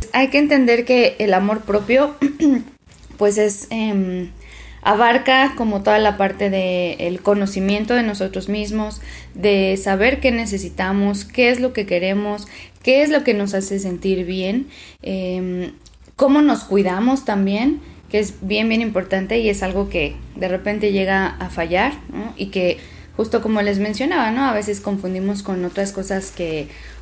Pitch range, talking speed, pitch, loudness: 190-235 Hz, 155 wpm, 205 Hz, -17 LUFS